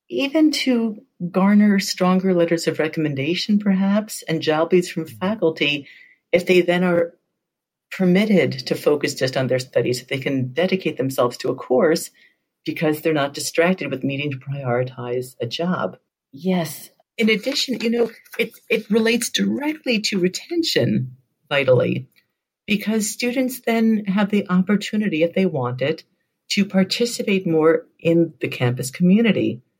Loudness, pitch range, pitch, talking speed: -20 LUFS, 155-215 Hz, 180 Hz, 145 wpm